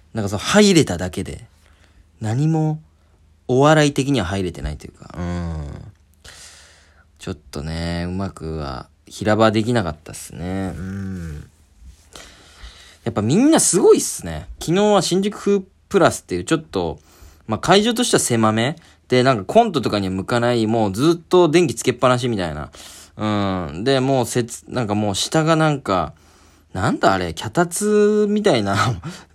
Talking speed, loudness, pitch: 315 characters per minute, -18 LUFS, 105 Hz